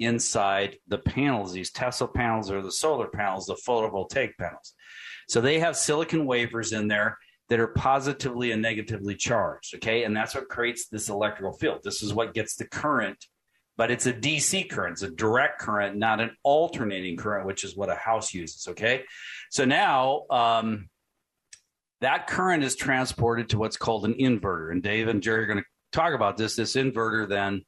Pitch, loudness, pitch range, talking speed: 110 Hz, -26 LUFS, 105-120 Hz, 185 wpm